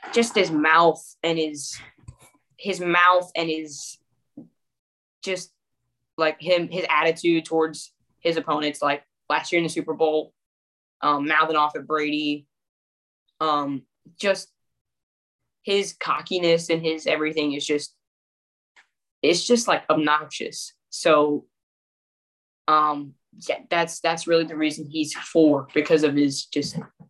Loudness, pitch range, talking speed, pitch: -23 LUFS, 140-165 Hz, 125 wpm, 155 Hz